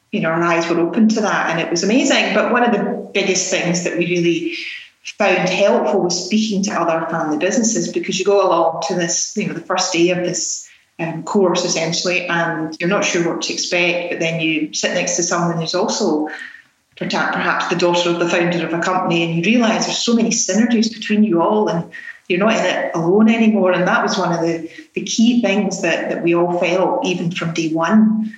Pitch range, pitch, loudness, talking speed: 170-210 Hz, 180 Hz, -17 LUFS, 220 wpm